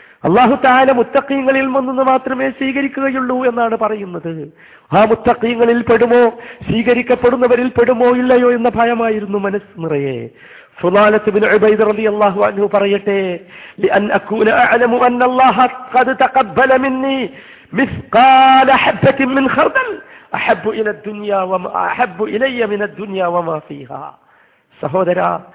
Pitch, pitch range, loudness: 235 Hz, 205-260 Hz, -13 LUFS